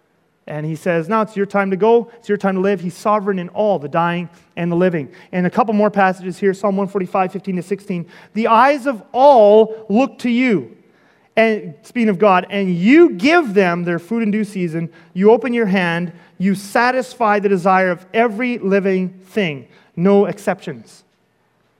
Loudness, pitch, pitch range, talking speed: -16 LUFS, 200 Hz, 180-220 Hz, 185 wpm